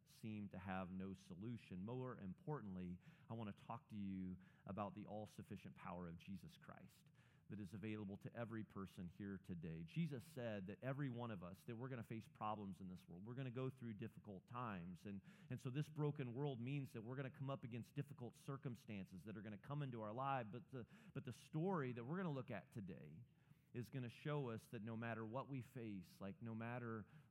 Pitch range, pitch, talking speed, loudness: 105-135 Hz, 120 Hz, 220 wpm, -52 LUFS